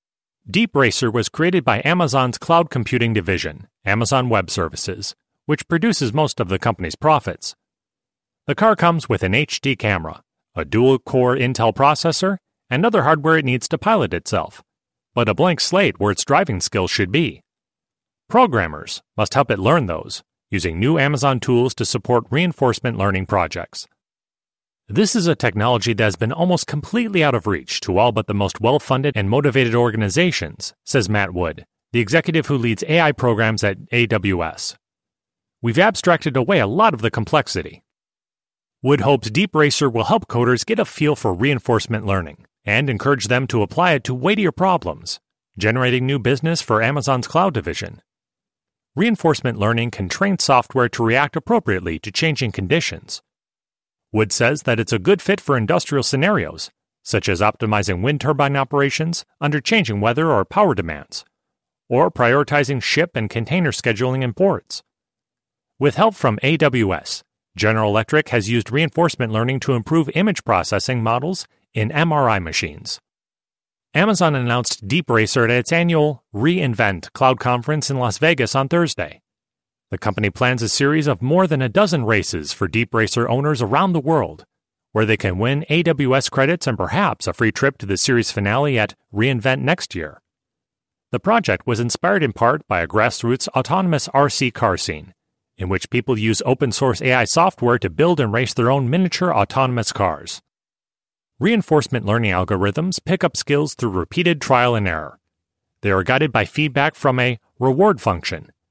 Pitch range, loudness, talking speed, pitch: 110-150 Hz, -18 LUFS, 160 wpm, 125 Hz